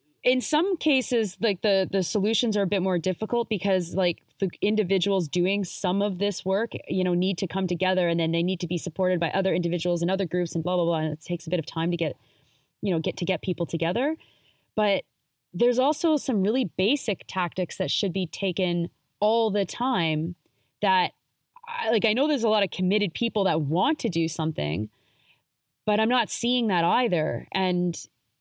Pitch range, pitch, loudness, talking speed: 170-215 Hz, 185 Hz, -26 LUFS, 205 wpm